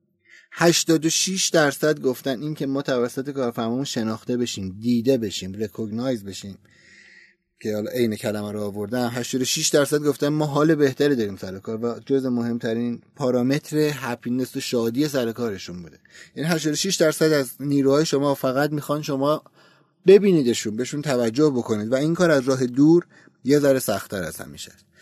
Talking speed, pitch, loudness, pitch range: 150 wpm, 130 Hz, -22 LUFS, 115-150 Hz